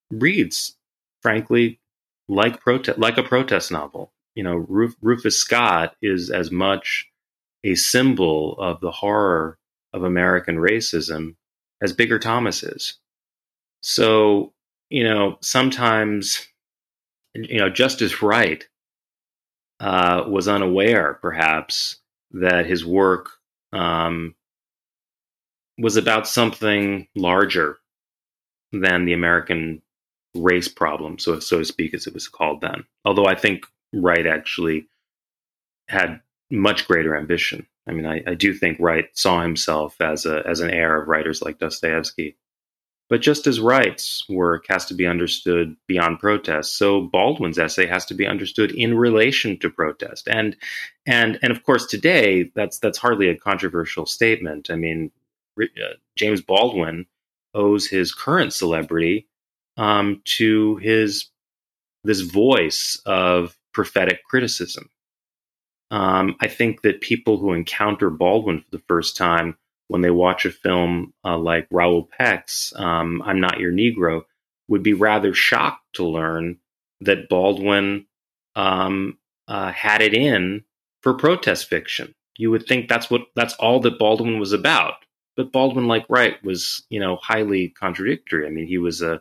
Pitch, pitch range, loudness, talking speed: 95 Hz, 85-110 Hz, -20 LUFS, 140 wpm